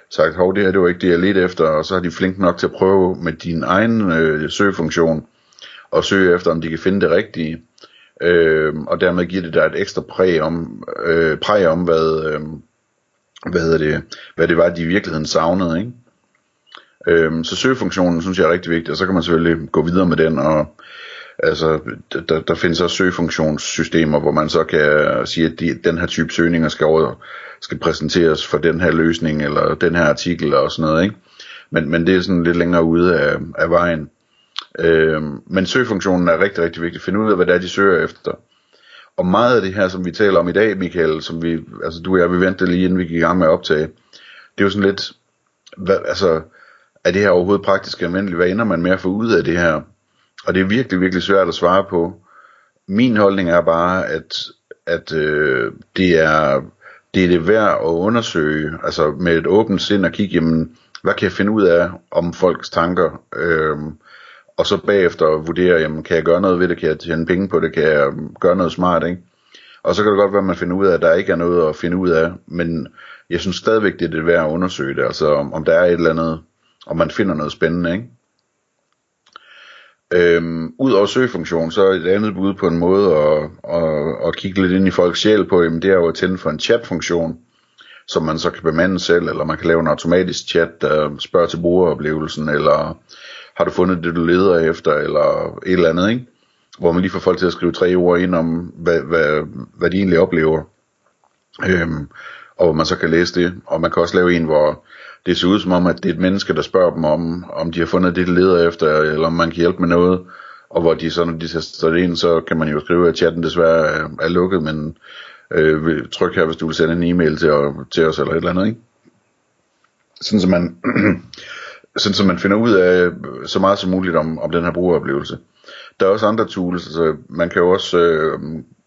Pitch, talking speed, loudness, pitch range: 85 Hz, 230 wpm, -16 LUFS, 80-95 Hz